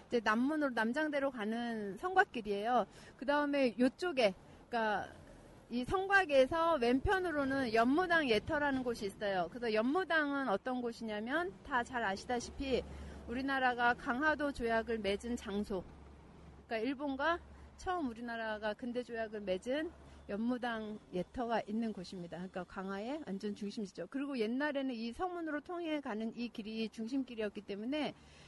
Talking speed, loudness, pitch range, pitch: 335 characters per minute, -36 LUFS, 215-285 Hz, 240 Hz